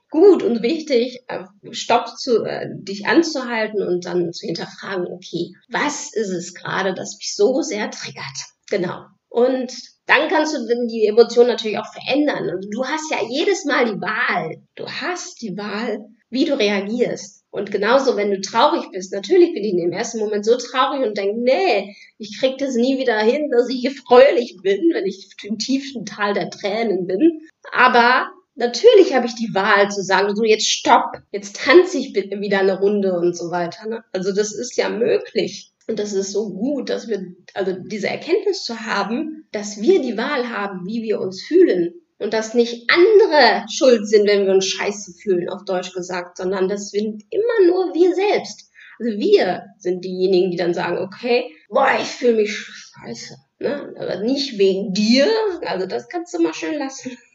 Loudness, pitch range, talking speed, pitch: -19 LUFS, 200-275 Hz, 185 wpm, 230 Hz